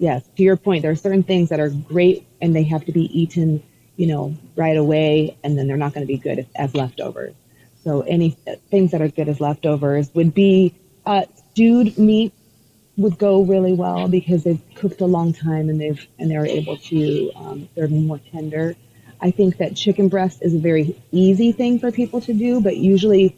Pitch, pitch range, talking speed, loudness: 165 Hz, 150-190 Hz, 210 wpm, -18 LUFS